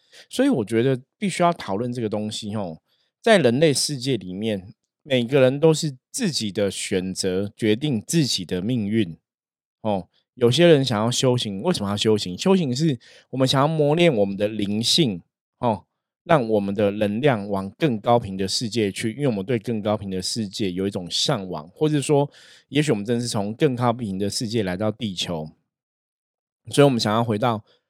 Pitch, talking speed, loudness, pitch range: 115 Hz, 275 characters per minute, -22 LUFS, 100-135 Hz